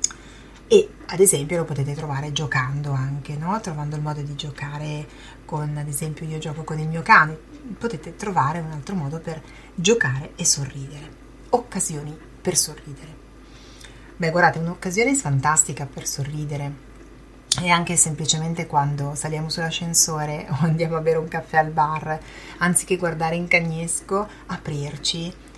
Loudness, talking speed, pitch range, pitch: -22 LUFS, 140 wpm, 145-170 Hz, 155 Hz